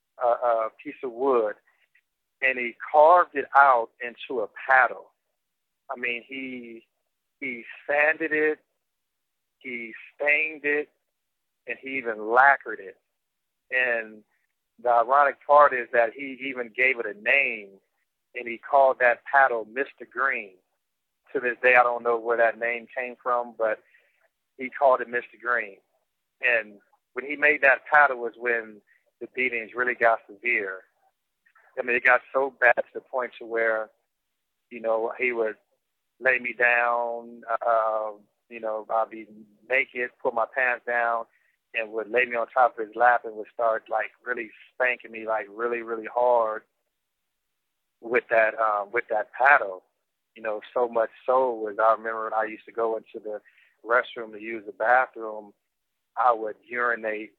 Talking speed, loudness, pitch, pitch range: 160 wpm, -24 LUFS, 120 Hz, 110-130 Hz